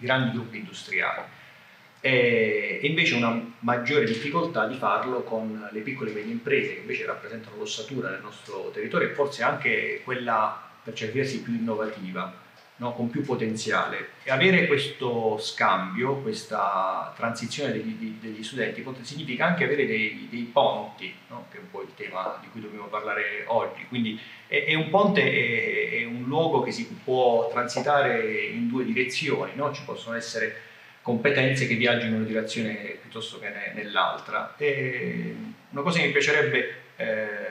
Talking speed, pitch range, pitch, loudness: 160 wpm, 115-175 Hz, 125 Hz, -26 LUFS